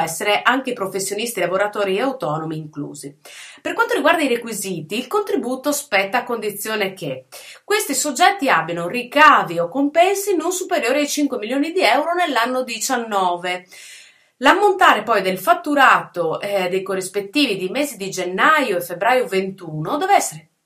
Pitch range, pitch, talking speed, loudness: 185-290 Hz, 225 Hz, 140 wpm, -18 LUFS